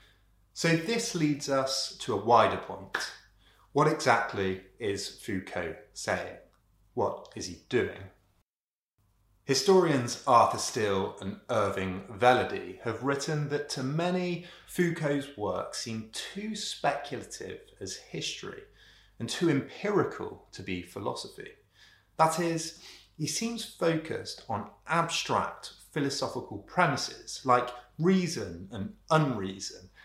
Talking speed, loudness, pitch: 110 wpm, -30 LUFS, 140 Hz